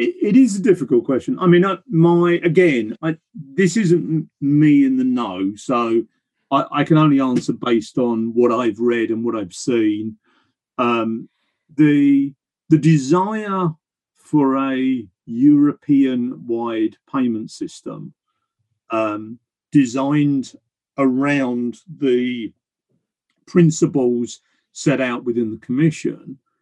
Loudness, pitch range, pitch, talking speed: -18 LUFS, 120-160 Hz, 135 Hz, 115 wpm